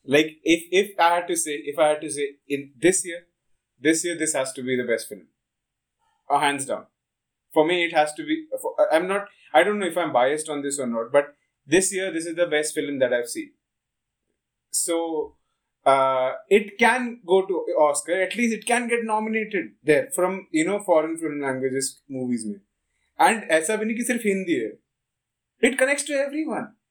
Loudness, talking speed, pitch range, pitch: -23 LUFS, 190 wpm, 145-215 Hz, 170 Hz